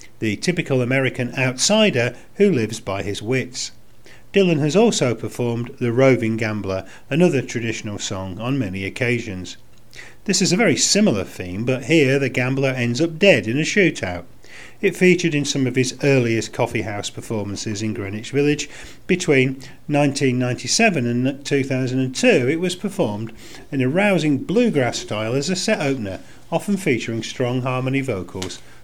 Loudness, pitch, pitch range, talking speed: -20 LUFS, 130 Hz, 115-150 Hz, 150 wpm